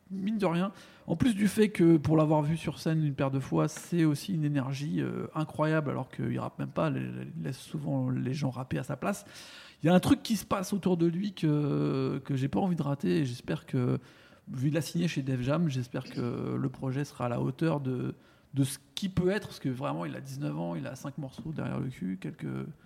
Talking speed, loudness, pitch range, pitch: 240 wpm, -31 LUFS, 135-170 Hz, 150 Hz